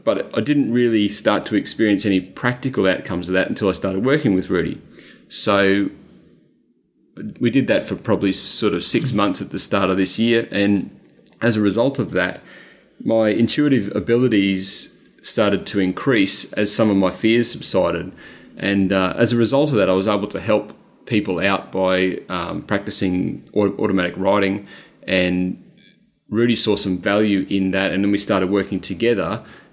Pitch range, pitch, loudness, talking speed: 95-110 Hz, 100 Hz, -19 LUFS, 170 wpm